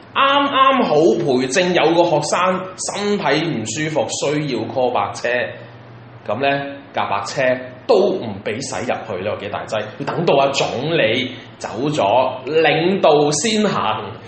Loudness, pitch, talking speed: -18 LUFS, 145 Hz, 210 characters per minute